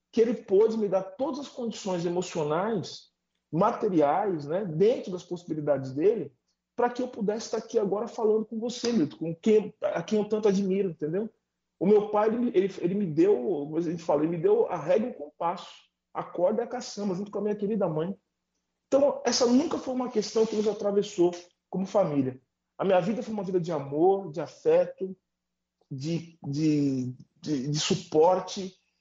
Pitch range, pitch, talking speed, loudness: 165-225 Hz, 195 Hz, 185 wpm, -27 LUFS